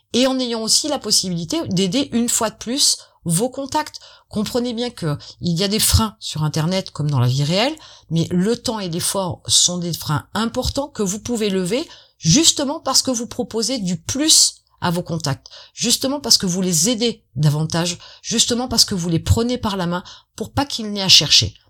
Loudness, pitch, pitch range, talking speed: -18 LUFS, 210 Hz, 170-245 Hz, 200 wpm